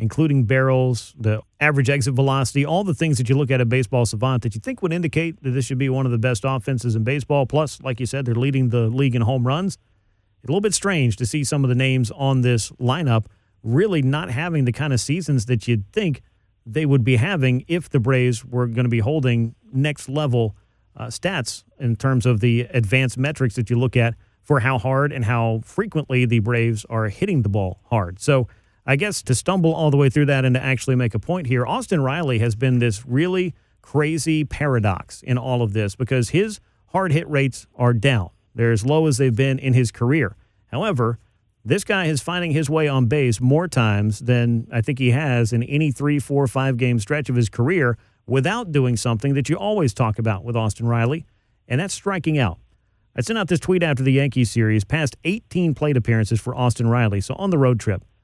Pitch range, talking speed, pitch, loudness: 115-145 Hz, 220 wpm, 130 Hz, -20 LUFS